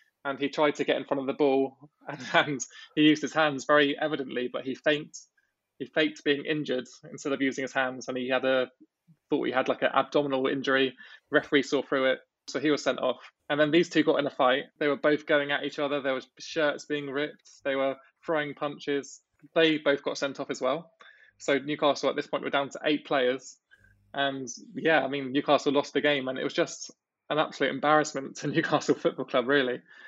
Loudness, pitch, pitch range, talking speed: -28 LUFS, 140 Hz, 135-150 Hz, 220 wpm